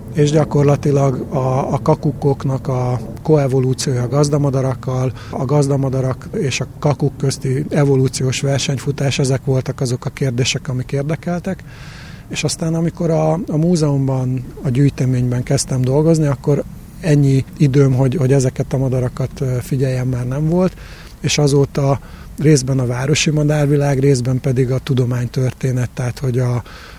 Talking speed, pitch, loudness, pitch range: 130 wpm, 135 Hz, -17 LUFS, 130-145 Hz